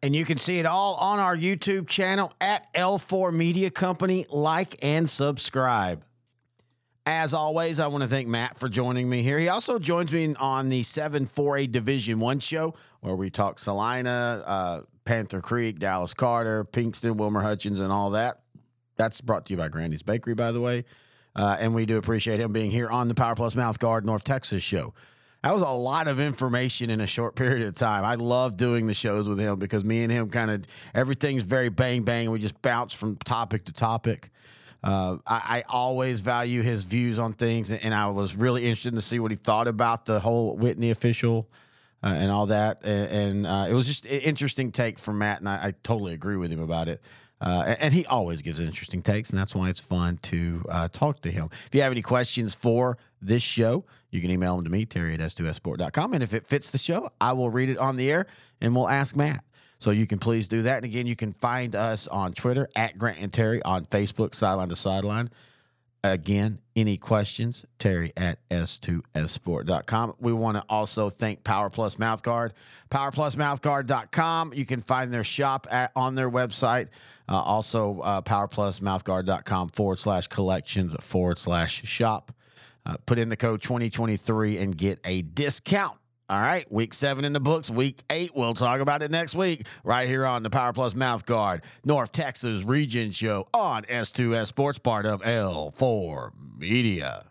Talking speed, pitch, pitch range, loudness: 195 wpm, 115 Hz, 105-130 Hz, -26 LUFS